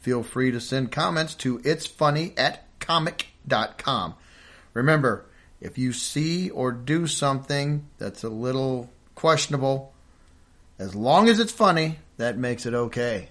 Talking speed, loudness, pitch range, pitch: 135 wpm, -24 LUFS, 120-155 Hz, 130 Hz